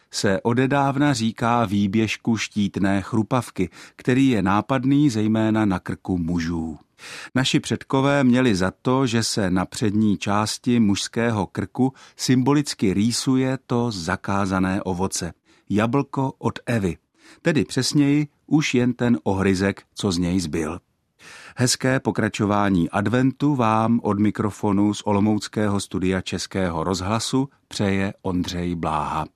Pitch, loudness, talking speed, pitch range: 110 Hz, -22 LUFS, 115 wpm, 95-125 Hz